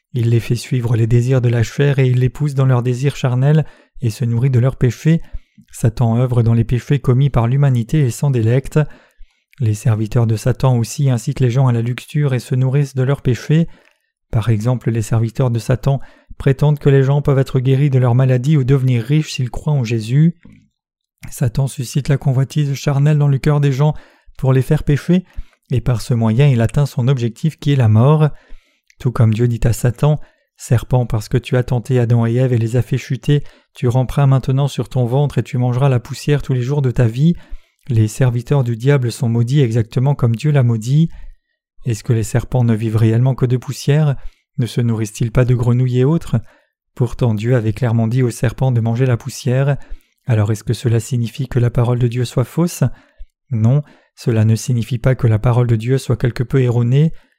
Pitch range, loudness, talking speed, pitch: 120-140 Hz, -16 LUFS, 210 wpm, 130 Hz